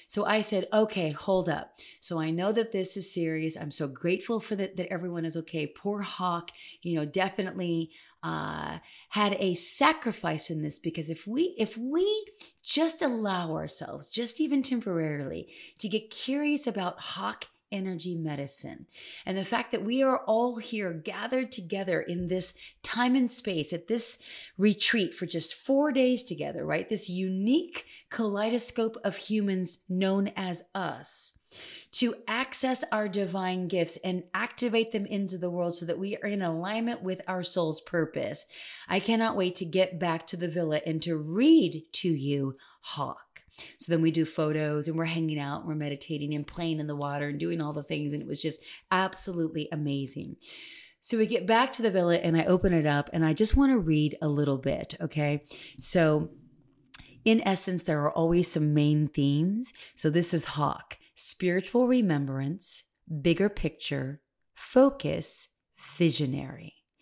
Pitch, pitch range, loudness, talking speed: 180 Hz, 160-215 Hz, -29 LUFS, 170 wpm